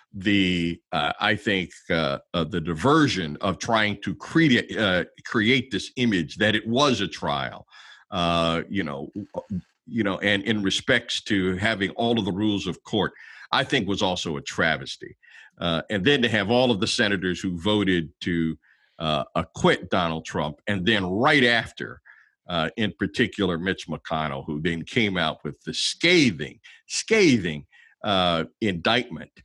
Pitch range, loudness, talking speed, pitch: 85-110 Hz, -24 LUFS, 160 wpm, 100 Hz